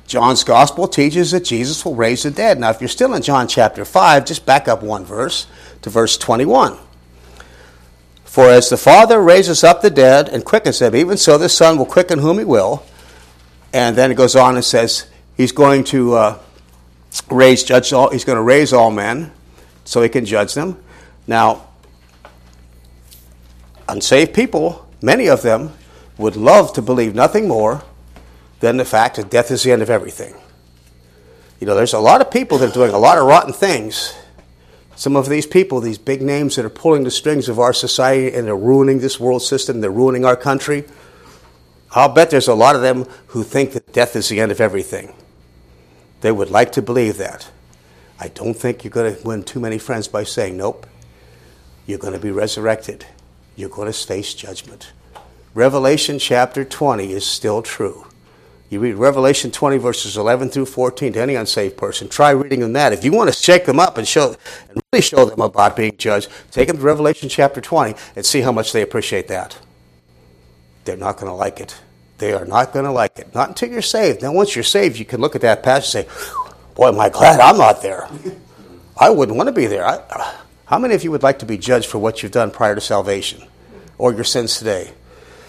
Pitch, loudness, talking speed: 120 Hz, -14 LUFS, 205 wpm